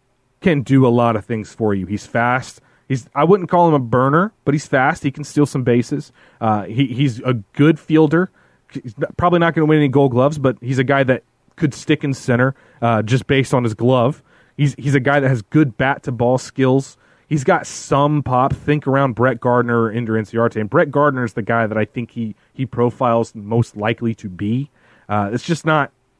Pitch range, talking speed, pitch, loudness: 120-145 Hz, 210 wpm, 130 Hz, -17 LUFS